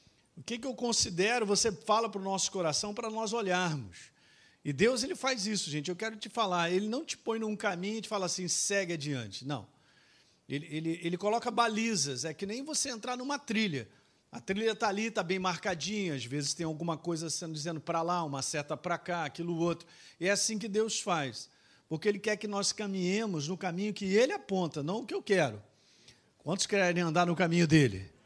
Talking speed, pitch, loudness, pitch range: 210 wpm, 185 Hz, -32 LUFS, 160-220 Hz